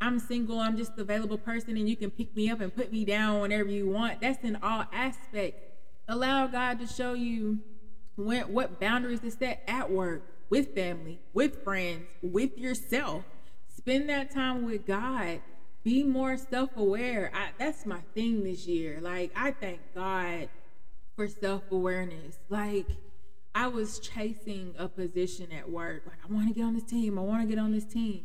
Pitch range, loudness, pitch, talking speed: 190-240 Hz, -32 LUFS, 215 Hz, 175 wpm